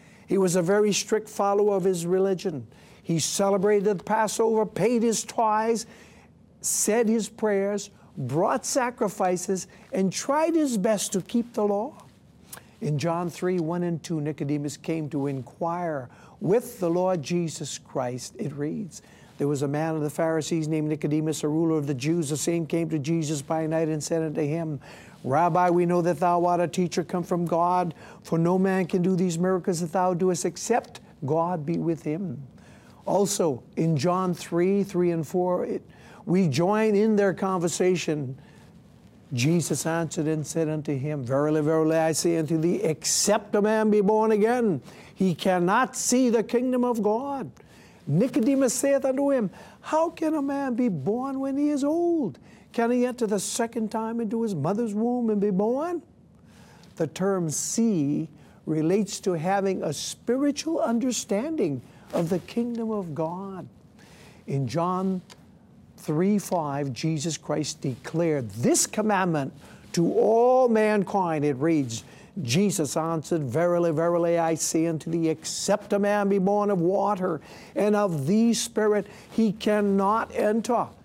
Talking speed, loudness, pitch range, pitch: 155 wpm, -25 LUFS, 160-215 Hz, 185 Hz